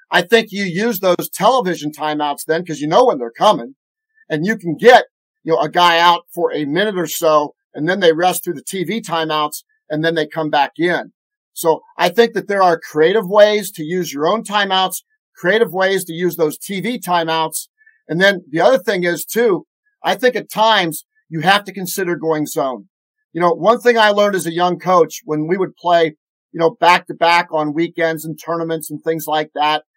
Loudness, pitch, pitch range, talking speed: -16 LUFS, 175 Hz, 160-205 Hz, 210 wpm